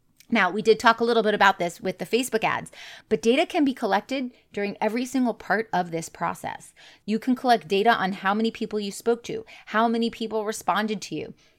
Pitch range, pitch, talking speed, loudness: 200-235 Hz, 220 Hz, 215 wpm, -24 LUFS